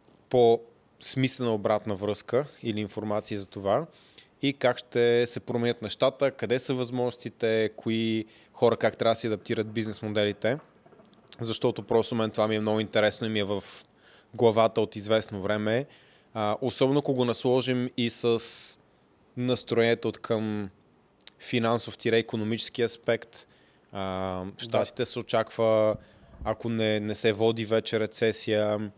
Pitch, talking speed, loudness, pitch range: 115 Hz, 135 wpm, -28 LUFS, 105-120 Hz